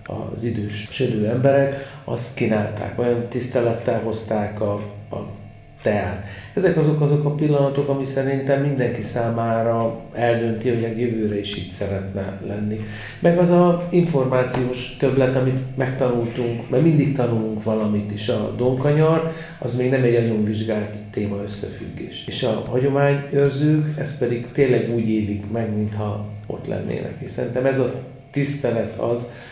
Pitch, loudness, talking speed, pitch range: 120 Hz, -21 LUFS, 140 wpm, 110-135 Hz